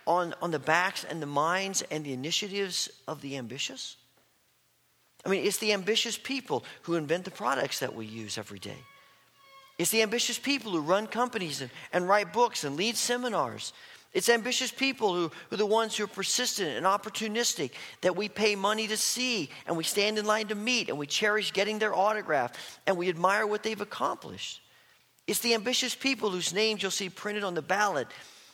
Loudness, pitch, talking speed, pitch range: -29 LUFS, 205 Hz, 195 wpm, 170-225 Hz